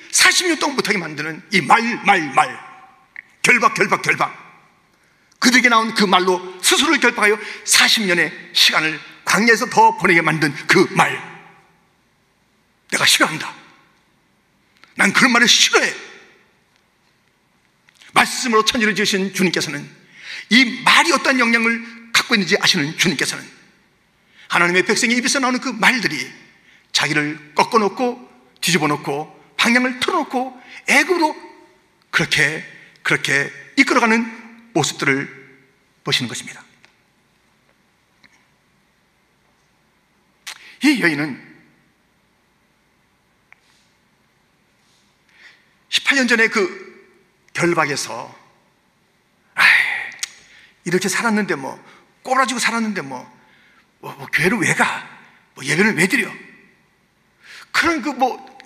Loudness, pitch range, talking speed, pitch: -16 LUFS, 185-260 Hz, 215 characters per minute, 225 Hz